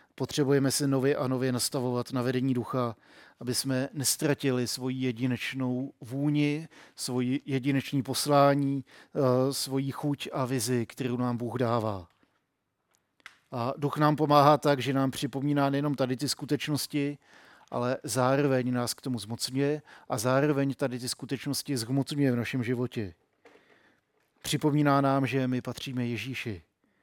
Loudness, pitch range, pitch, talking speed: -29 LUFS, 125-140 Hz, 135 Hz, 130 wpm